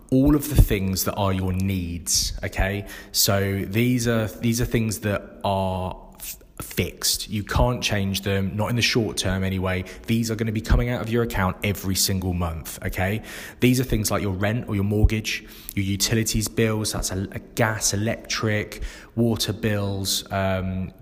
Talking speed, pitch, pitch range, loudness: 180 wpm, 105 Hz, 95-115 Hz, -24 LUFS